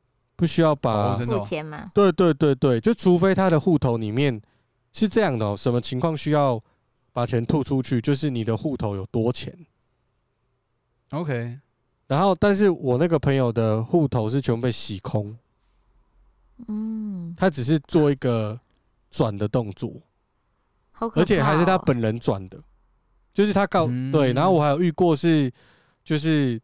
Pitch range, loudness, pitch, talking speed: 120-165 Hz, -22 LUFS, 130 Hz, 230 characters per minute